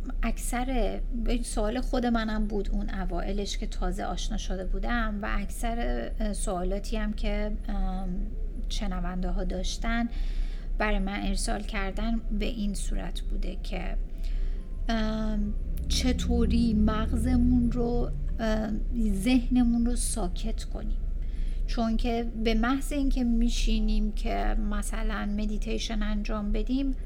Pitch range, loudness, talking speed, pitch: 185-230 Hz, -30 LUFS, 105 wpm, 210 Hz